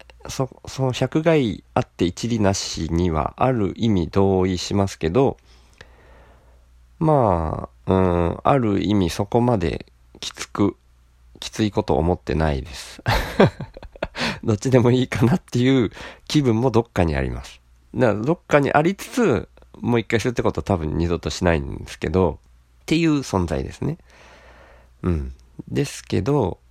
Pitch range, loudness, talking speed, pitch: 70-120 Hz, -21 LUFS, 280 characters per minute, 95 Hz